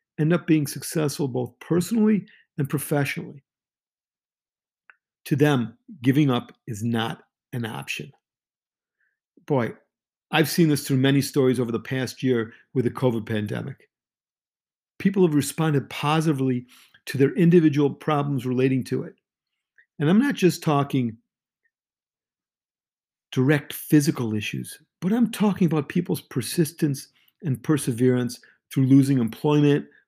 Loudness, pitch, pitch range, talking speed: -23 LUFS, 140 Hz, 125-160 Hz, 120 wpm